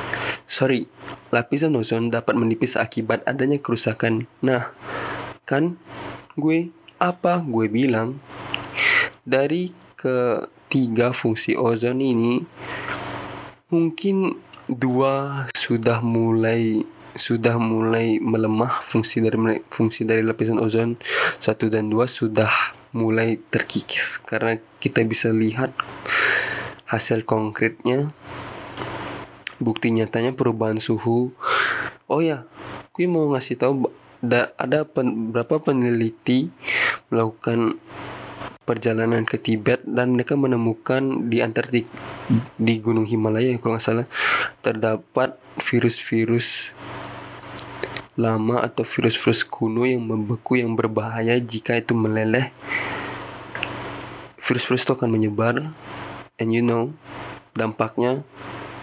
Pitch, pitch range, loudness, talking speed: 115 Hz, 115-130 Hz, -22 LUFS, 95 wpm